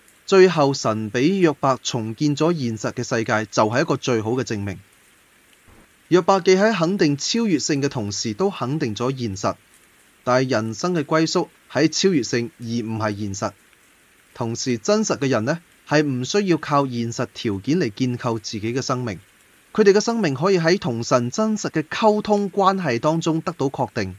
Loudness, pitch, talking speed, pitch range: -21 LUFS, 135 Hz, 260 characters per minute, 115-165 Hz